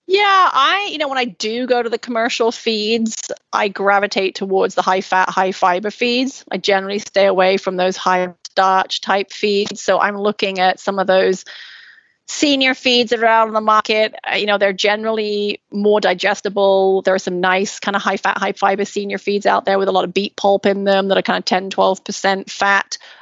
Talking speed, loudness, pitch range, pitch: 210 wpm, -16 LUFS, 190-220 Hz, 200 Hz